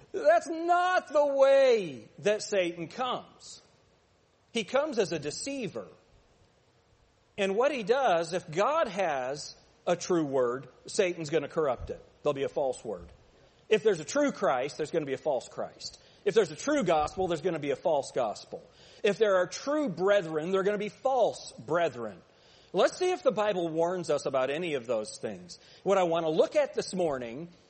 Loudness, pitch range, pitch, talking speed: -29 LUFS, 170-280 Hz, 195 Hz, 180 wpm